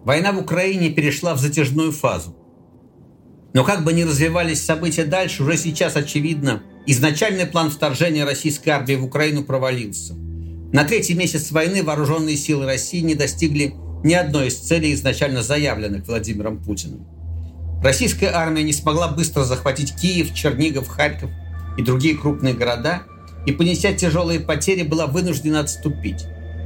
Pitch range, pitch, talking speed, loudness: 125-165 Hz, 150 Hz, 140 wpm, -19 LUFS